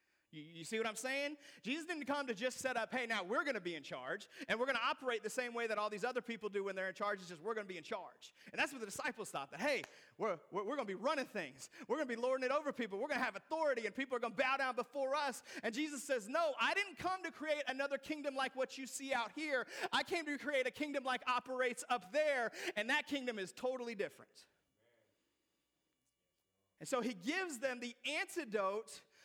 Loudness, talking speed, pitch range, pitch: -40 LUFS, 250 wpm, 230-290 Hz, 260 Hz